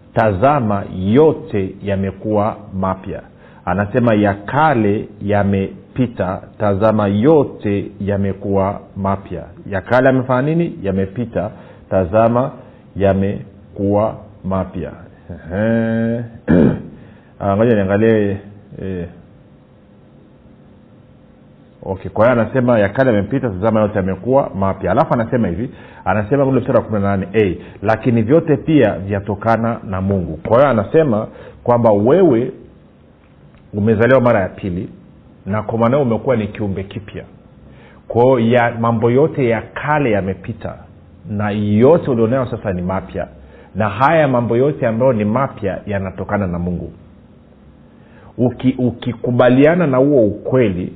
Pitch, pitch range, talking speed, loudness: 105 Hz, 95-120 Hz, 105 wpm, -16 LUFS